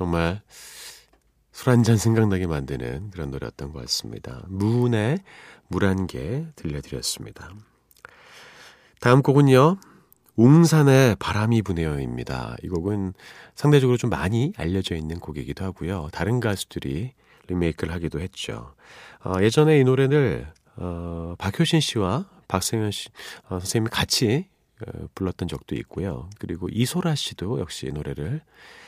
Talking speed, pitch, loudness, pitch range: 285 characters per minute, 100 Hz, -23 LUFS, 85-125 Hz